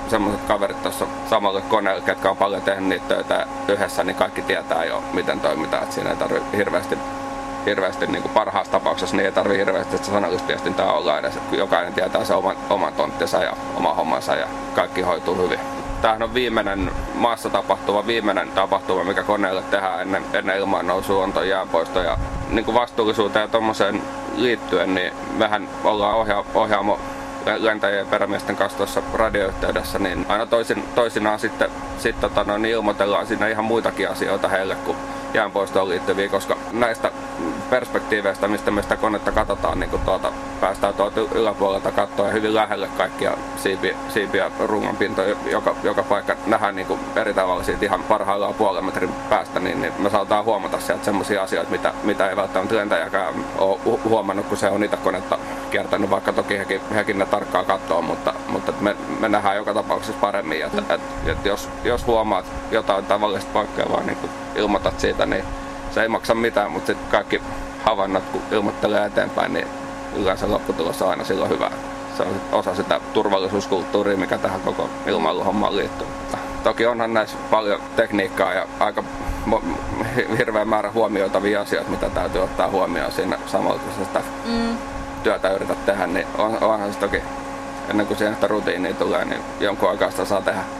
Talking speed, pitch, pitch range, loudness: 160 wpm, 110 Hz, 105-120 Hz, -21 LUFS